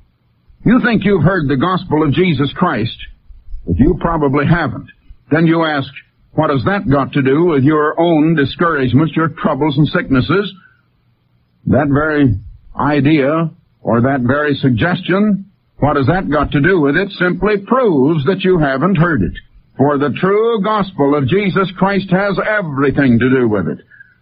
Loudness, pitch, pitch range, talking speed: -14 LUFS, 150 Hz, 140-185 Hz, 160 wpm